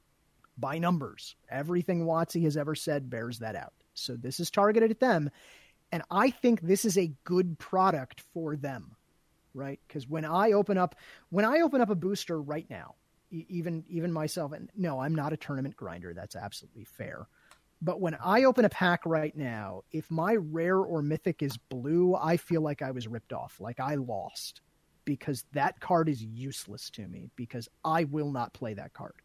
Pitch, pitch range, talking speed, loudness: 160 Hz, 135-180 Hz, 190 wpm, -30 LUFS